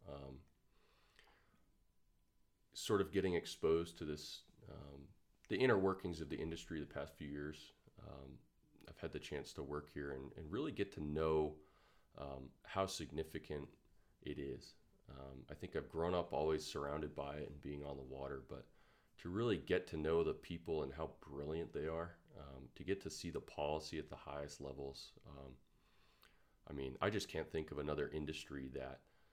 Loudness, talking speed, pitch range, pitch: -44 LUFS, 180 wpm, 70-85 Hz, 75 Hz